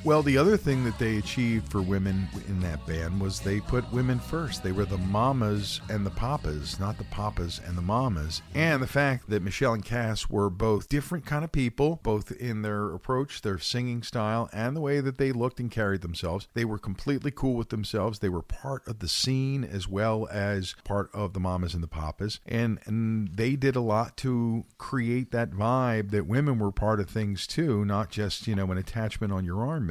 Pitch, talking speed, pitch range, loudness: 110 Hz, 215 wpm, 100-125 Hz, -29 LUFS